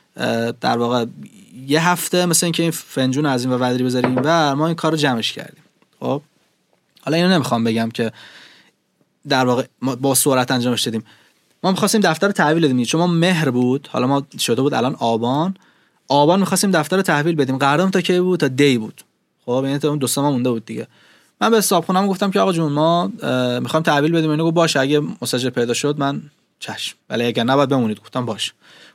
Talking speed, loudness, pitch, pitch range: 195 wpm, -18 LUFS, 145 Hz, 125-170 Hz